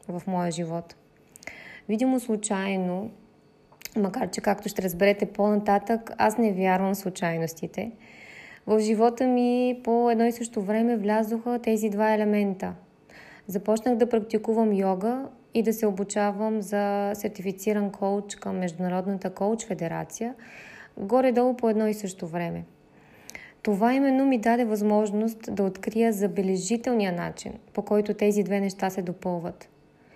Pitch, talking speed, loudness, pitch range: 210 Hz, 130 wpm, -26 LUFS, 195-230 Hz